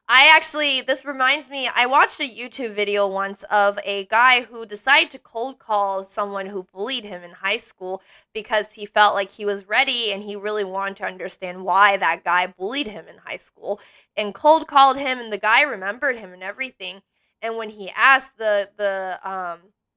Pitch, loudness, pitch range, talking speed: 210 Hz, -20 LUFS, 195-255 Hz, 195 wpm